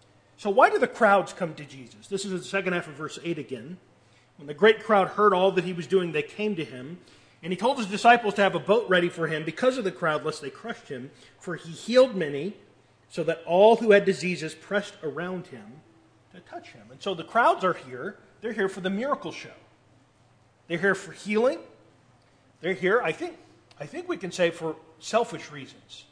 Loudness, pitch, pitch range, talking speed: -25 LUFS, 175 Hz, 145-200 Hz, 220 wpm